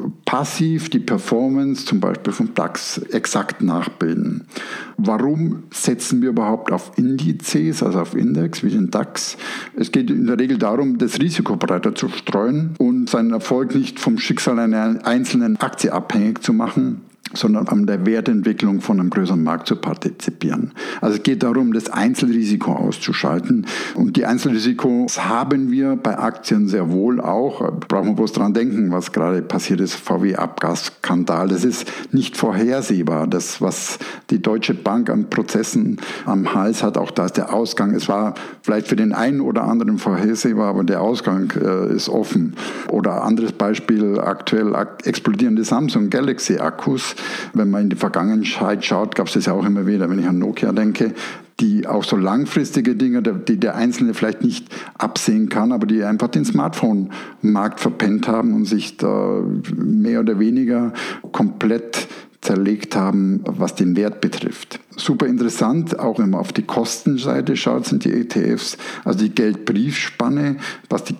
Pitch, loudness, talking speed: 215 Hz, -19 LUFS, 160 wpm